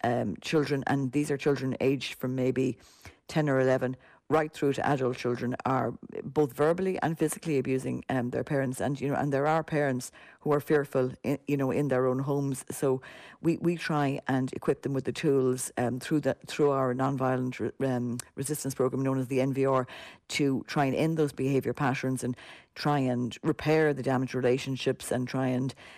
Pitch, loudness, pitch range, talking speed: 135 Hz, -29 LUFS, 130-145 Hz, 195 wpm